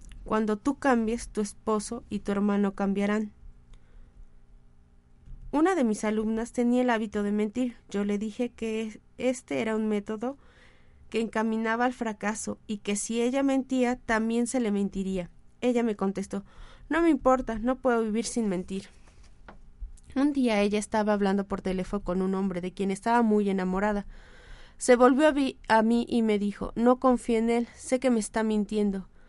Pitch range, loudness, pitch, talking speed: 200-240 Hz, -27 LUFS, 220 Hz, 170 wpm